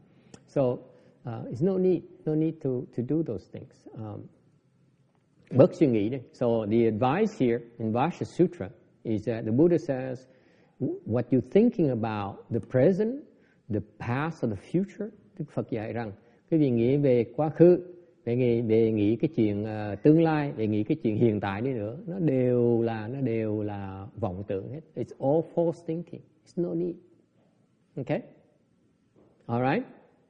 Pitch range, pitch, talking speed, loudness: 115-165 Hz, 130 Hz, 170 wpm, -27 LUFS